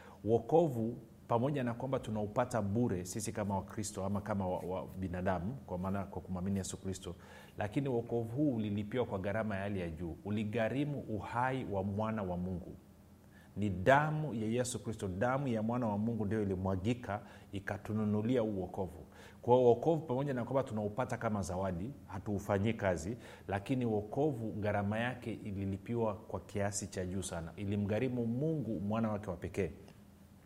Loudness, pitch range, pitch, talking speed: -36 LUFS, 95-115 Hz, 105 Hz, 150 wpm